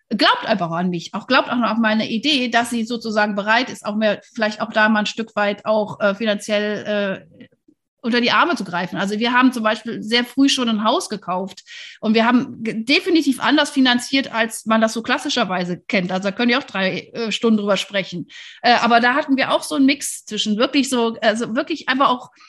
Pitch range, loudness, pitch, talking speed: 210-260 Hz, -18 LUFS, 230 Hz, 225 wpm